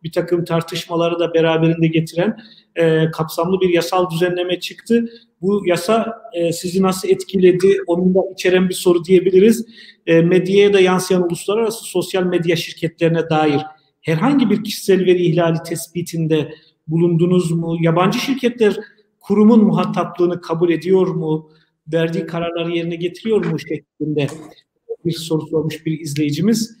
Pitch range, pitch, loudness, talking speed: 165-190 Hz, 175 Hz, -17 LUFS, 130 wpm